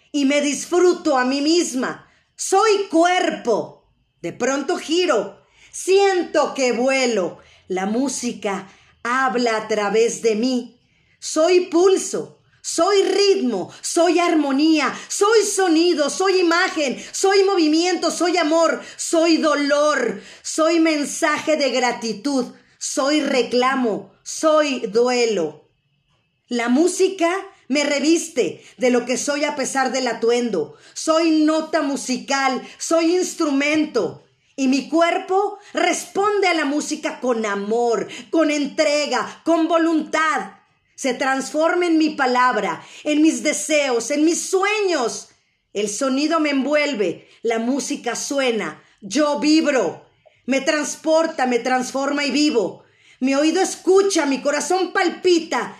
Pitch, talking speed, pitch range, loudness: 295 Hz, 115 wpm, 250-335 Hz, -19 LUFS